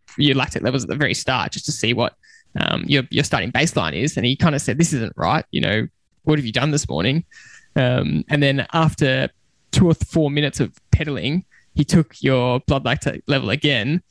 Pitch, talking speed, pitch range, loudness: 145 Hz, 215 wpm, 130-155 Hz, -20 LUFS